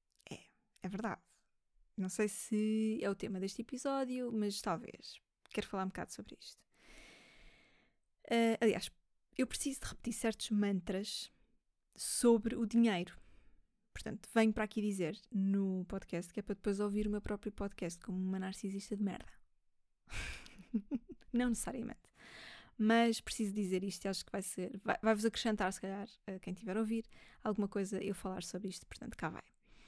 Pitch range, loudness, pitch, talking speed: 190-225 Hz, -38 LUFS, 205 Hz, 160 wpm